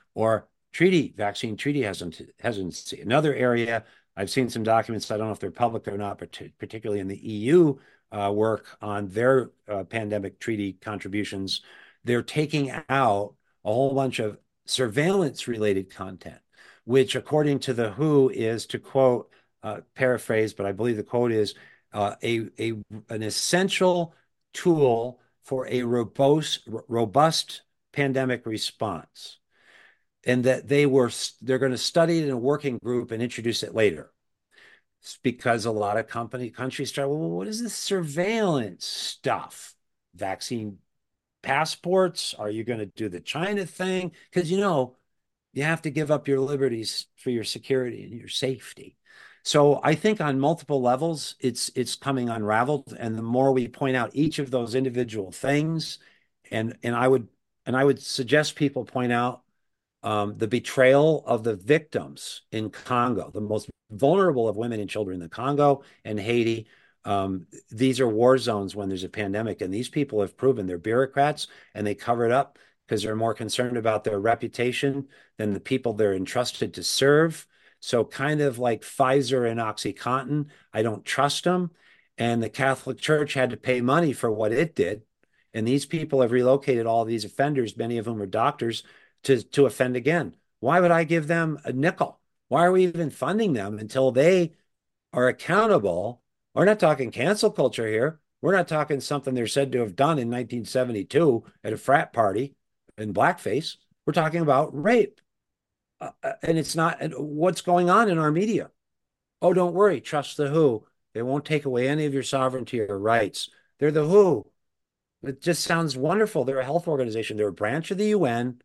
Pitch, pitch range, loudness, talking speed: 130 Hz, 110-150 Hz, -25 LUFS, 175 wpm